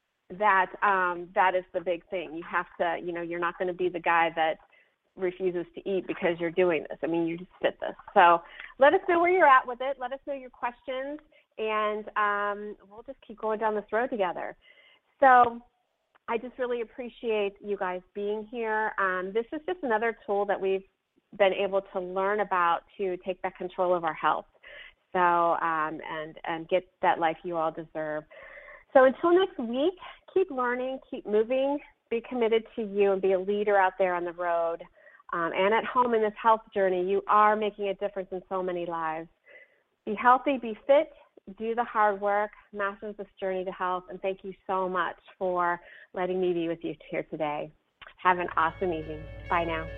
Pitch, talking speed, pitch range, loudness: 200 Hz, 200 wpm, 180-230 Hz, -28 LUFS